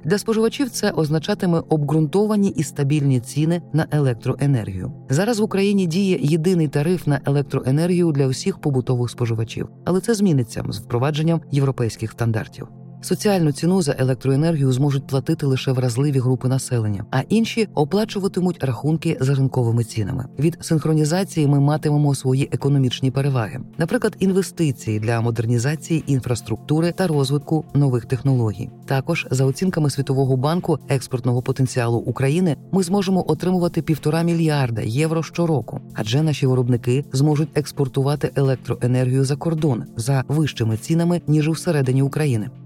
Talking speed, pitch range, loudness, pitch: 130 wpm, 130-165 Hz, -20 LUFS, 145 Hz